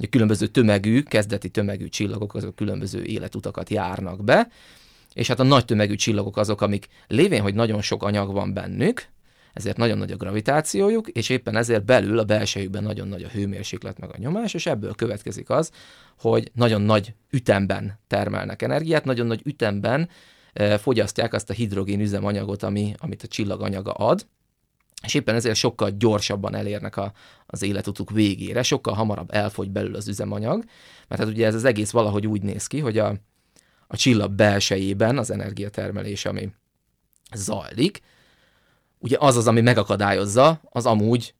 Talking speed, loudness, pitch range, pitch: 160 wpm, -23 LUFS, 100-115 Hz, 105 Hz